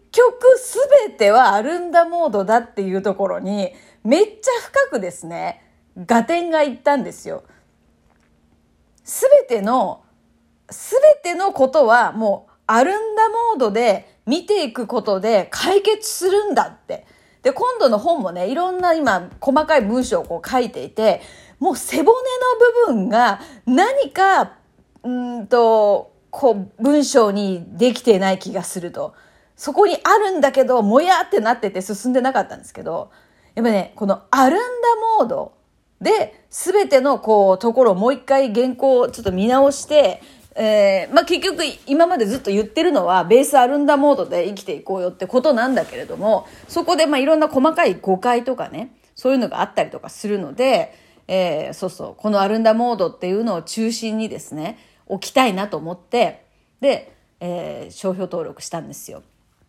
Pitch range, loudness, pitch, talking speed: 205-320 Hz, -17 LUFS, 255 Hz, 315 characters per minute